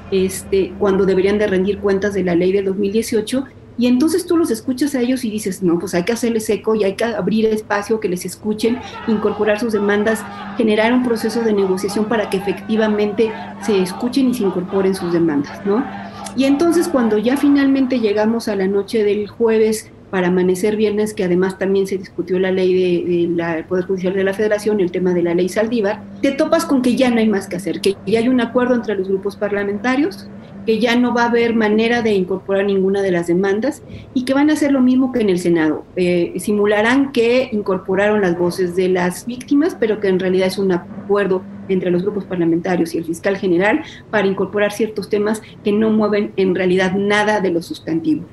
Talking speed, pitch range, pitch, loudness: 210 wpm, 190-225 Hz, 205 Hz, -17 LUFS